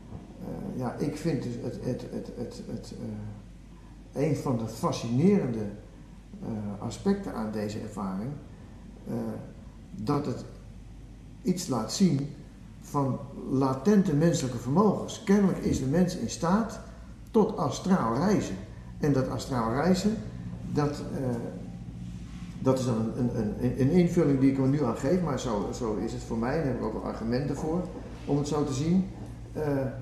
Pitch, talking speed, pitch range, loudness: 135 Hz, 160 wpm, 110-165 Hz, -29 LUFS